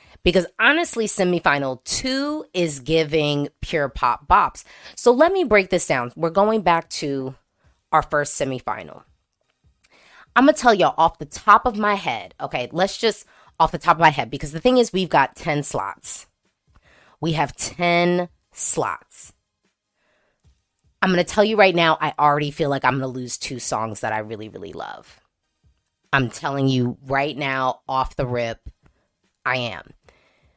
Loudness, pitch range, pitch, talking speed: -20 LUFS, 135-185 Hz, 155 Hz, 170 wpm